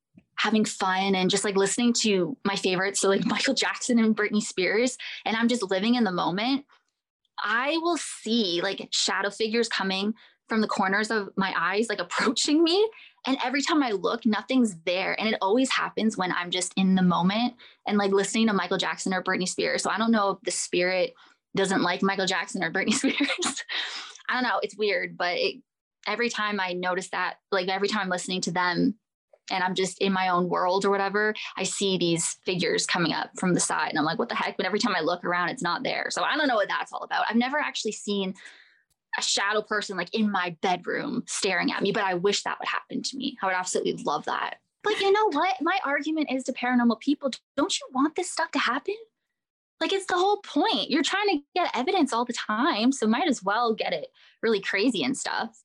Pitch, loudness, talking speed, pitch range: 220 Hz, -26 LUFS, 220 wpm, 195-265 Hz